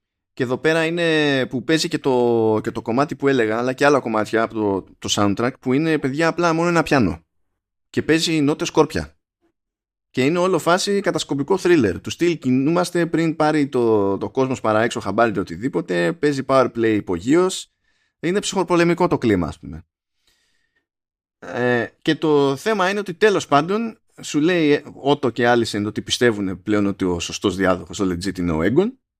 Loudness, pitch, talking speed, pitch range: -19 LUFS, 130 Hz, 170 wpm, 105-160 Hz